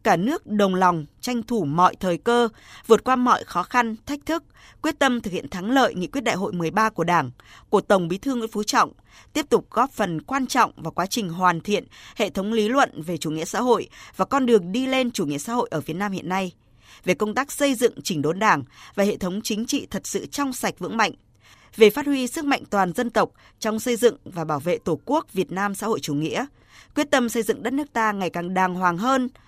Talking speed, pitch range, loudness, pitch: 250 wpm, 180-245 Hz, -23 LUFS, 215 Hz